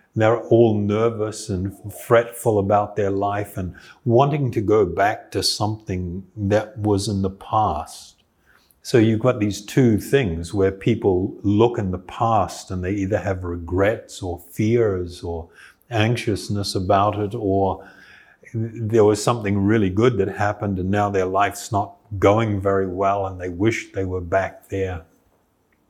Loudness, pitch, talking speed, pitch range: -21 LUFS, 100 Hz, 155 wpm, 95-110 Hz